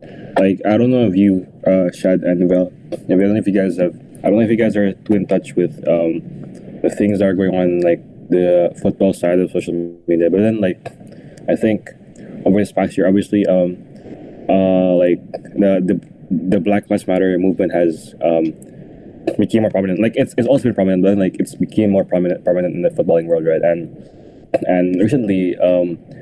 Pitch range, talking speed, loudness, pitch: 90-100 Hz, 205 wpm, -16 LUFS, 95 Hz